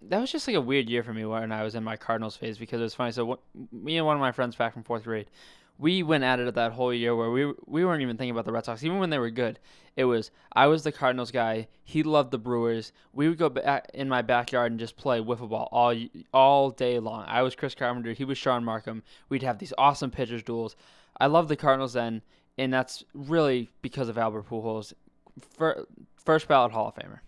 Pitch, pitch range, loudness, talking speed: 125 Hz, 115-135 Hz, -27 LUFS, 250 wpm